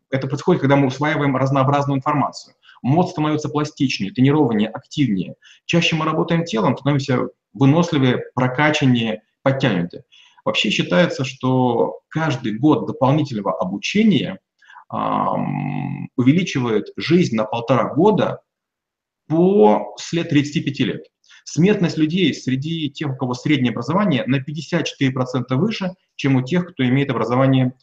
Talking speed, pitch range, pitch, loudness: 115 wpm, 130-155 Hz, 140 Hz, -19 LUFS